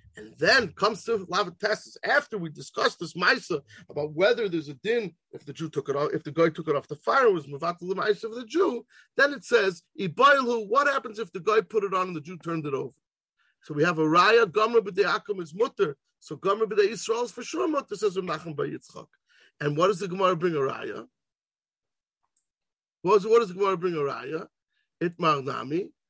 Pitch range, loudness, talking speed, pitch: 165-230 Hz, -26 LUFS, 215 wpm, 195 Hz